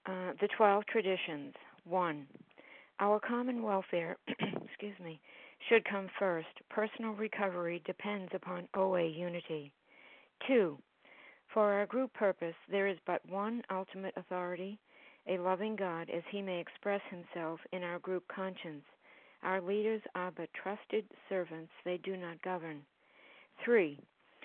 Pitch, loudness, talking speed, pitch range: 190 Hz, -37 LUFS, 135 wpm, 175-205 Hz